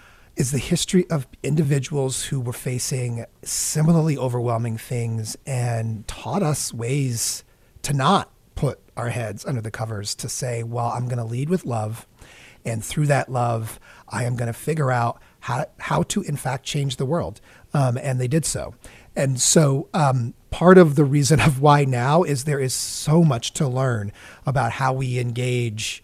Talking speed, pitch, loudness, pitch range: 175 wpm, 130 Hz, -22 LUFS, 115-145 Hz